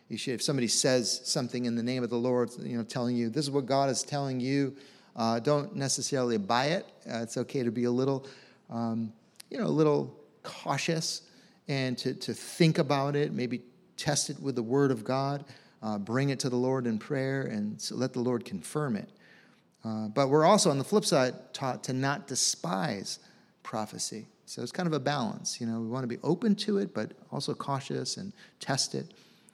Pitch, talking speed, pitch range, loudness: 135 Hz, 210 wpm, 120-150 Hz, -30 LUFS